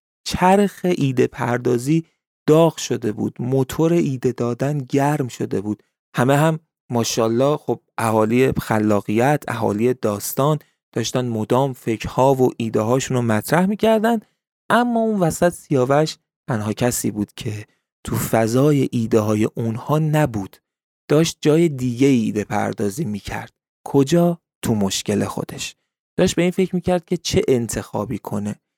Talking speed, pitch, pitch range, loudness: 130 wpm, 130 Hz, 115-155 Hz, -20 LUFS